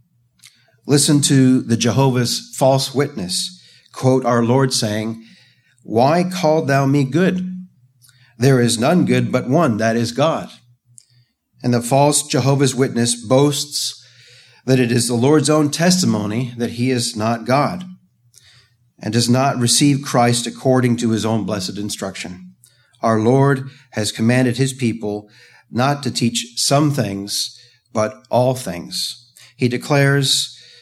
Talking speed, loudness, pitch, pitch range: 135 wpm, -17 LUFS, 125 Hz, 115-140 Hz